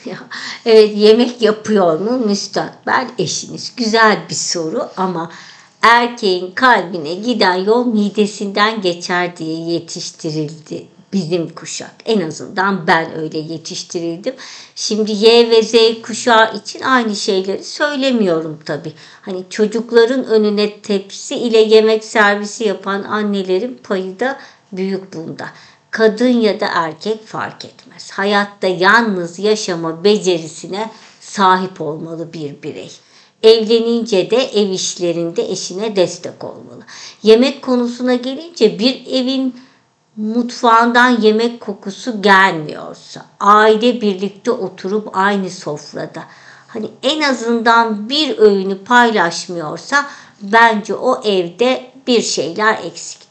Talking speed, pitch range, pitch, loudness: 105 wpm, 185-230 Hz, 210 Hz, -15 LUFS